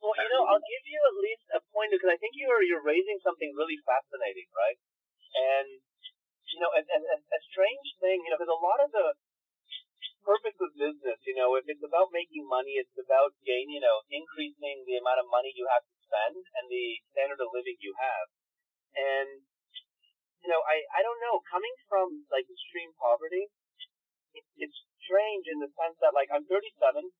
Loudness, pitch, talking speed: -30 LUFS, 215 Hz, 195 wpm